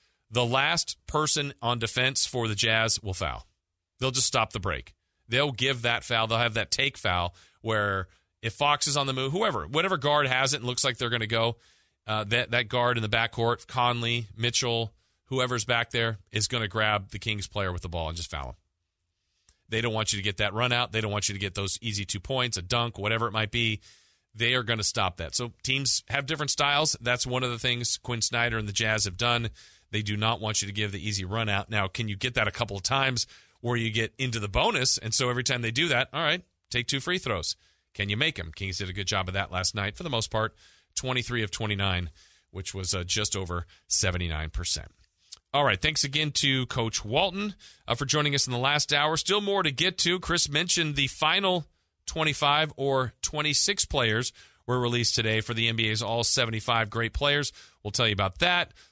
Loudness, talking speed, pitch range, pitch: -26 LUFS, 230 wpm, 105-130 Hz, 115 Hz